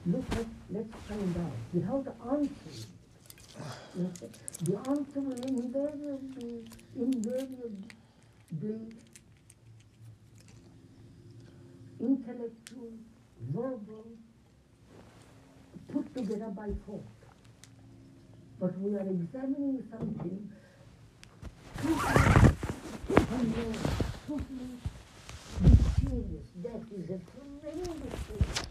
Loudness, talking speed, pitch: -33 LUFS, 75 wpm, 210 Hz